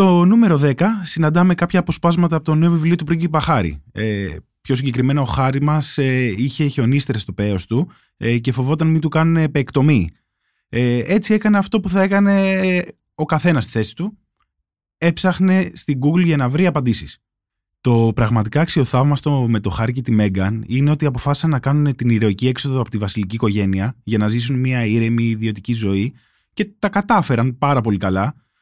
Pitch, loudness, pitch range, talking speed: 135 Hz, -17 LUFS, 115-165 Hz, 180 wpm